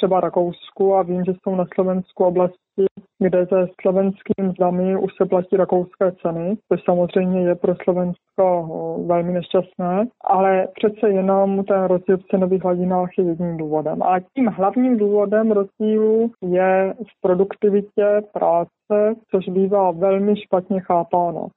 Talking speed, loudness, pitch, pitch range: 135 wpm, -19 LUFS, 190 Hz, 180-200 Hz